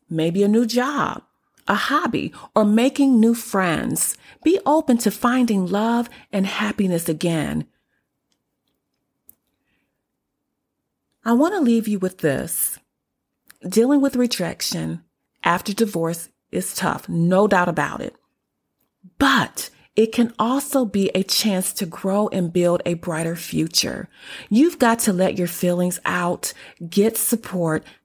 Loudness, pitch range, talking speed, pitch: -20 LUFS, 175-235 Hz, 125 wpm, 200 Hz